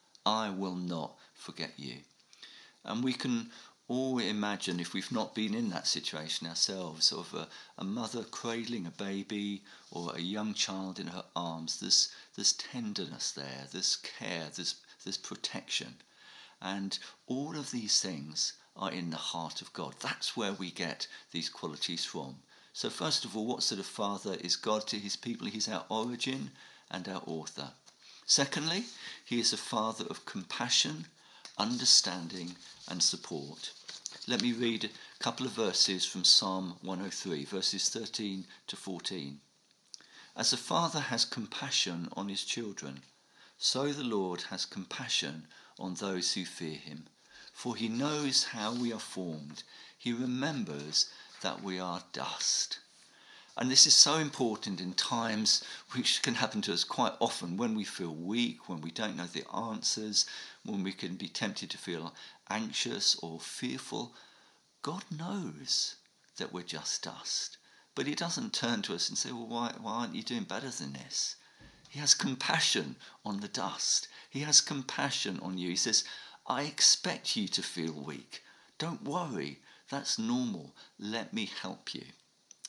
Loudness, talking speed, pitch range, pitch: -32 LUFS, 155 wpm, 90-125 Hz, 100 Hz